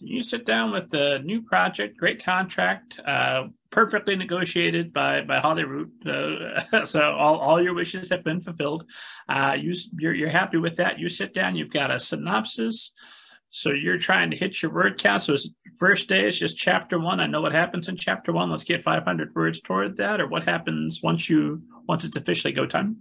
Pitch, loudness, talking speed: 165 Hz, -24 LUFS, 205 wpm